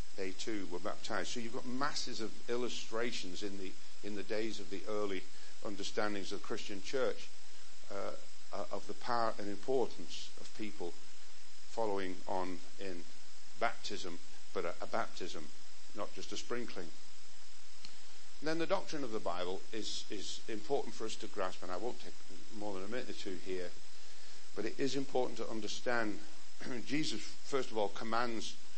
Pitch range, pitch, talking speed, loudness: 95-120 Hz, 105 Hz, 165 wpm, -41 LUFS